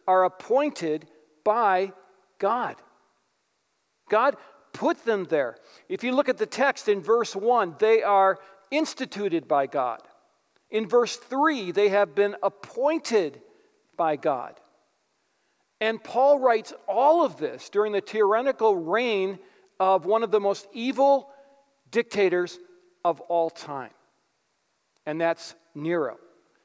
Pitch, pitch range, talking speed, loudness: 210 Hz, 185-265 Hz, 120 wpm, -25 LUFS